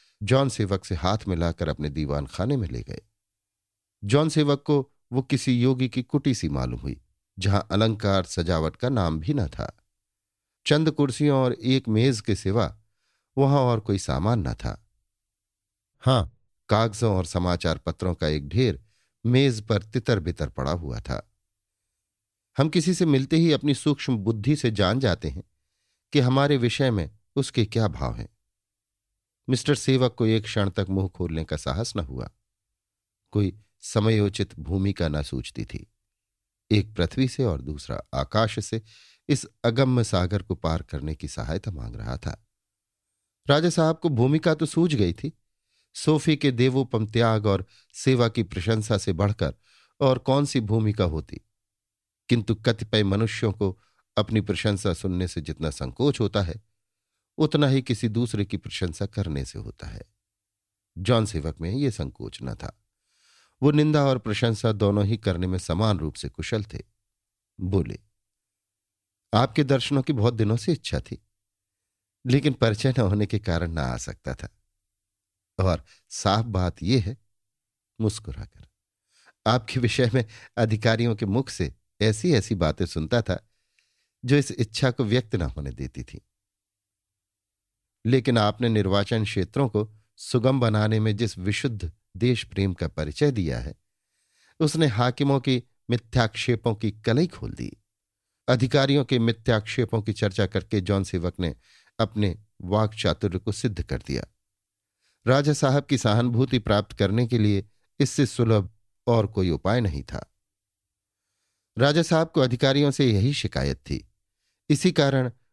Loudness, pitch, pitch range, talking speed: -25 LUFS, 105 Hz, 95-125 Hz, 150 wpm